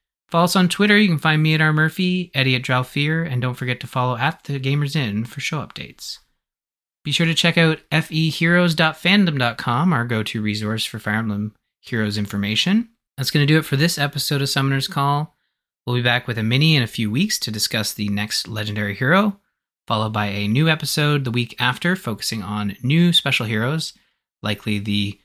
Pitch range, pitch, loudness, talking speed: 110-160 Hz, 140 Hz, -19 LUFS, 195 wpm